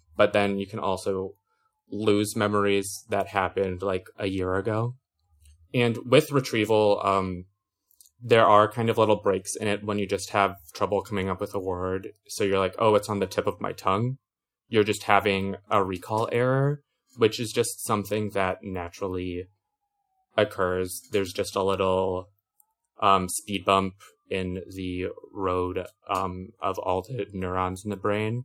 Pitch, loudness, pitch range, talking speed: 100 Hz, -26 LUFS, 95-110 Hz, 160 wpm